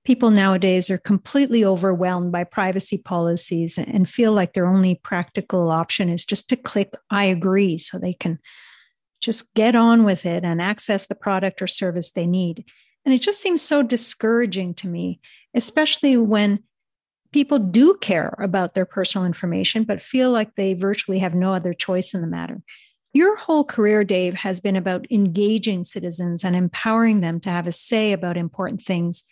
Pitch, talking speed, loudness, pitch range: 195 Hz, 175 wpm, -20 LUFS, 180-220 Hz